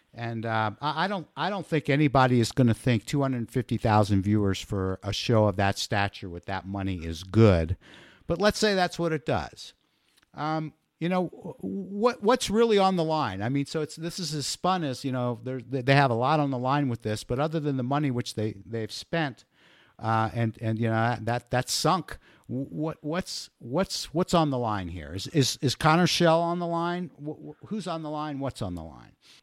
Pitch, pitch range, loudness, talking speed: 135 Hz, 110-160 Hz, -27 LUFS, 215 wpm